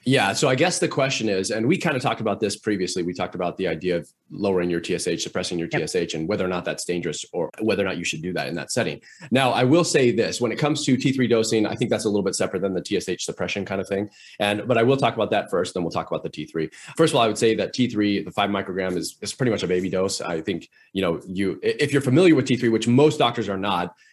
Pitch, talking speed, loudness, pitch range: 100 Hz, 290 wpm, -23 LUFS, 90-120 Hz